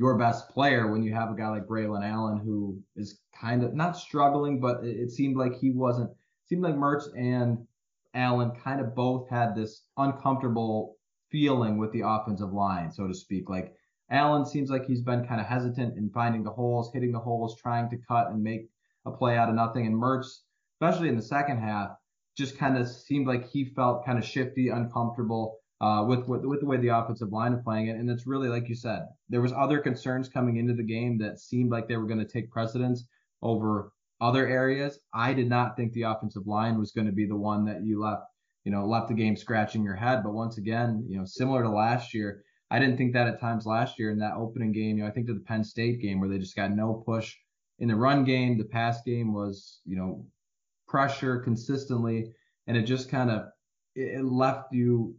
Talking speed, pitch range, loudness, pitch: 225 wpm, 110-130 Hz, -29 LUFS, 120 Hz